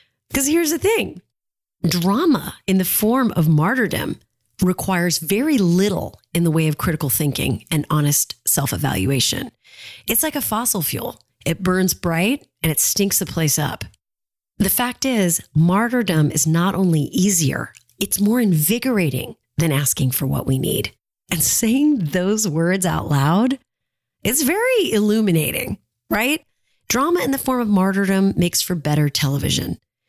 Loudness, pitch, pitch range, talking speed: -19 LUFS, 180 Hz, 150-215 Hz, 150 wpm